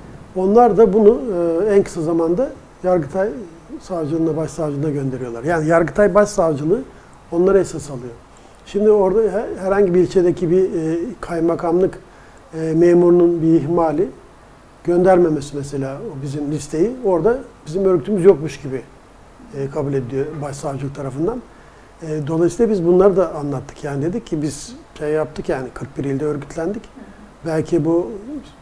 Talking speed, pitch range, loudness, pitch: 120 wpm, 150-190 Hz, -18 LUFS, 170 Hz